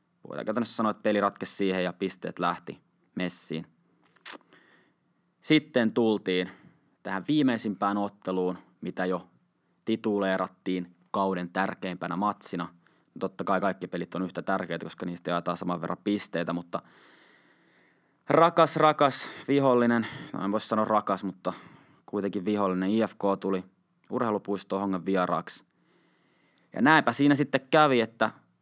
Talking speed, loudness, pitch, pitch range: 120 wpm, -28 LUFS, 95 Hz, 90-110 Hz